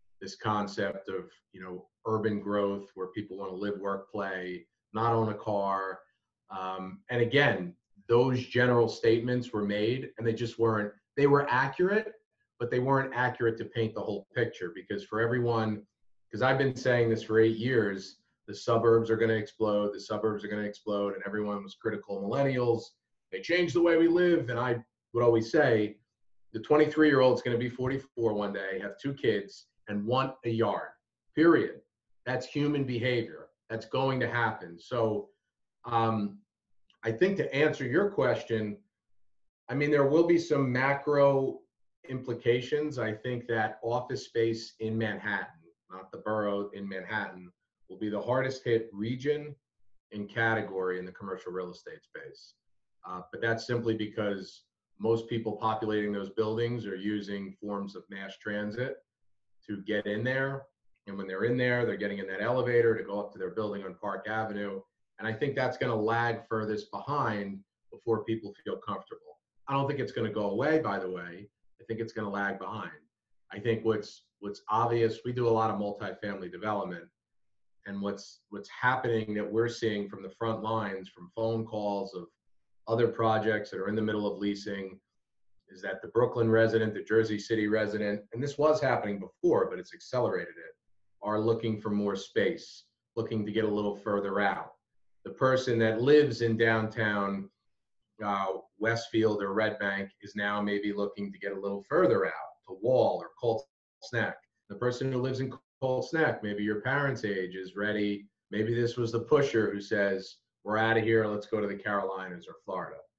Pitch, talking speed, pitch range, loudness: 110 Hz, 180 wpm, 100-120 Hz, -30 LUFS